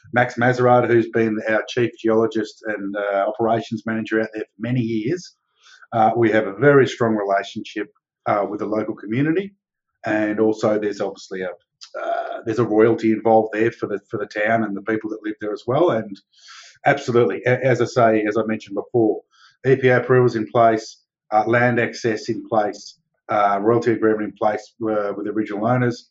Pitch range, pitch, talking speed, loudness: 110-120 Hz, 110 Hz, 185 wpm, -20 LUFS